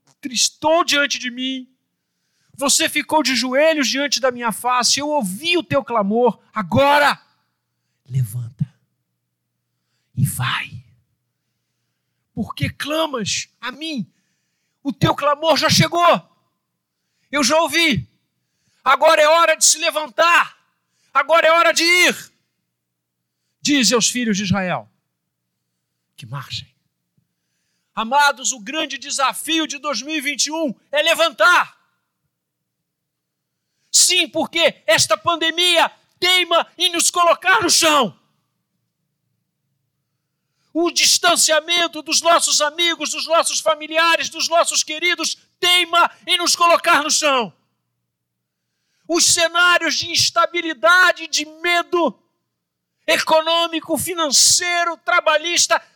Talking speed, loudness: 100 wpm, -16 LUFS